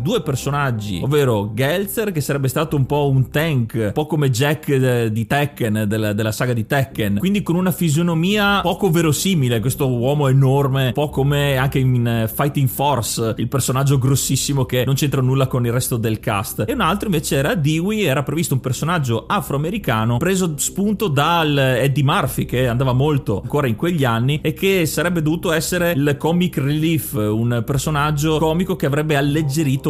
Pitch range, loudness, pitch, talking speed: 130-160 Hz, -18 LUFS, 140 Hz, 175 wpm